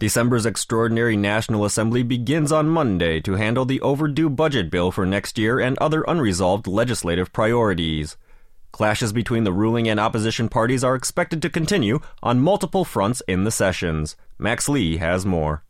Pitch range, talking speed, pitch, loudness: 95-130 Hz, 160 wpm, 115 Hz, -21 LUFS